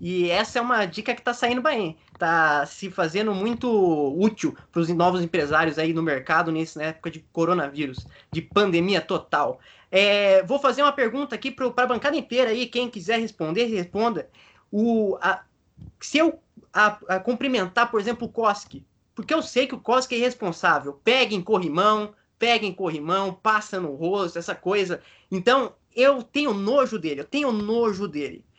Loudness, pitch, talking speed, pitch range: -23 LUFS, 210 Hz, 170 wpm, 175-245 Hz